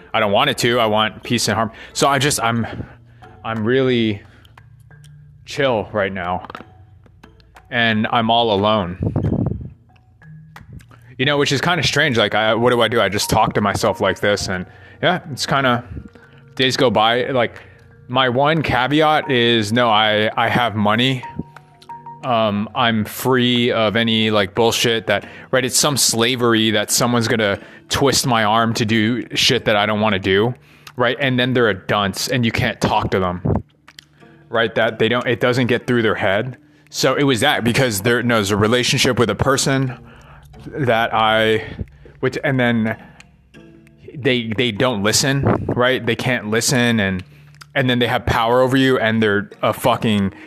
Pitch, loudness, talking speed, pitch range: 120 Hz, -17 LUFS, 175 wpm, 110-130 Hz